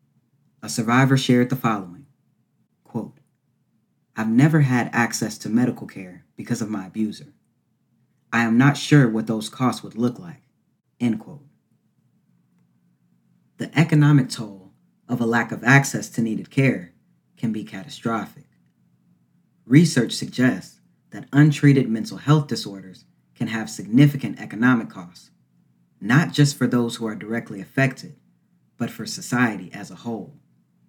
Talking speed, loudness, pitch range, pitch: 135 wpm, -21 LUFS, 100-130 Hz, 115 Hz